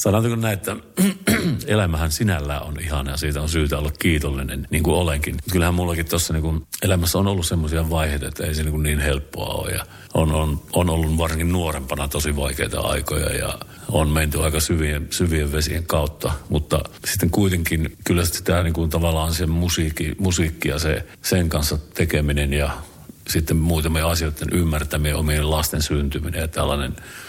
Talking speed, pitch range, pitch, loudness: 170 wpm, 75-85 Hz, 80 Hz, -22 LUFS